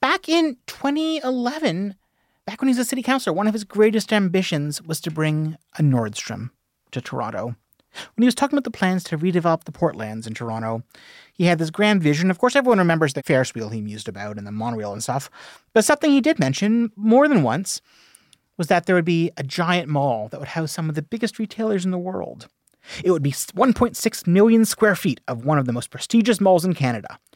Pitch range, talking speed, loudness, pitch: 140-225 Hz, 215 wpm, -21 LUFS, 180 Hz